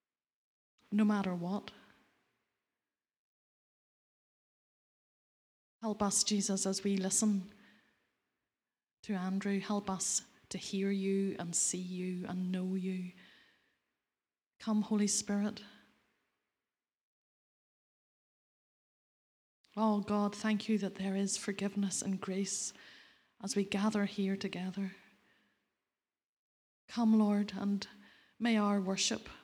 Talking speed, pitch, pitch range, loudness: 95 wpm, 200 Hz, 195-210 Hz, -35 LUFS